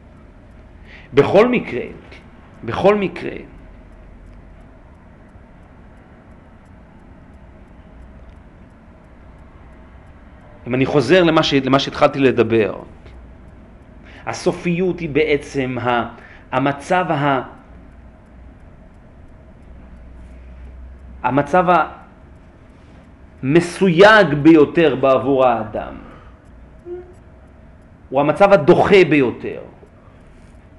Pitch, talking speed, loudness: 95 Hz, 45 wpm, -15 LUFS